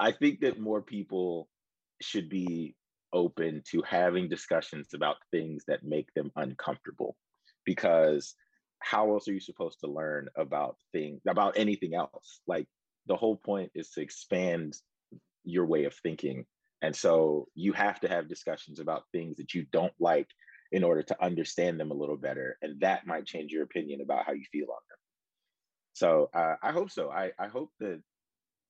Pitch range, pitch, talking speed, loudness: 75-100 Hz, 90 Hz, 175 wpm, -32 LUFS